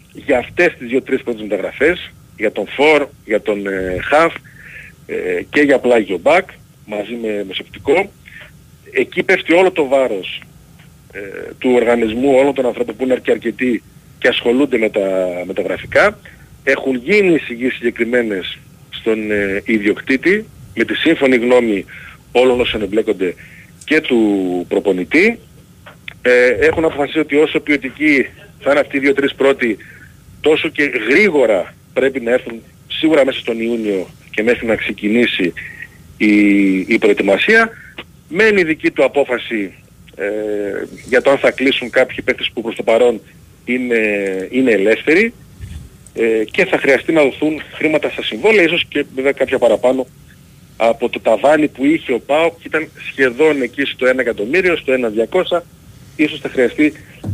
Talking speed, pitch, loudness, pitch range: 140 wpm, 130 Hz, -15 LUFS, 110-150 Hz